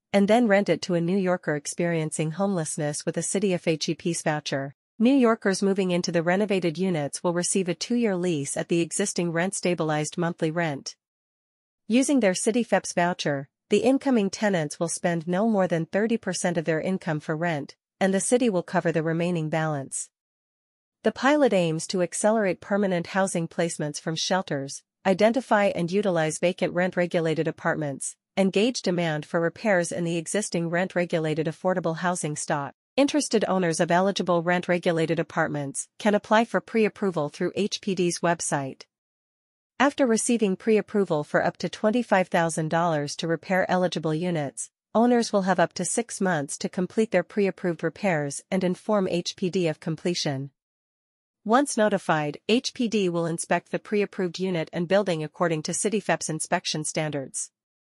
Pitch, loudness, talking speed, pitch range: 175 Hz, -25 LUFS, 155 wpm, 165-200 Hz